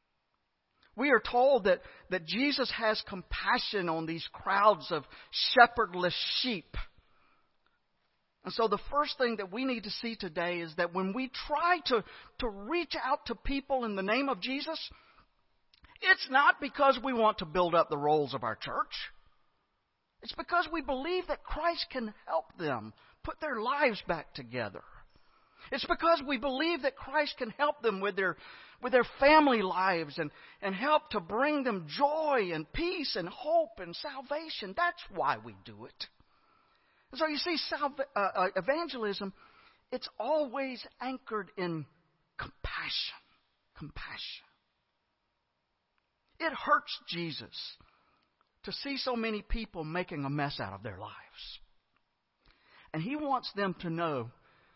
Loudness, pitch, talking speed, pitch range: -31 LUFS, 240 Hz, 150 wpm, 185-290 Hz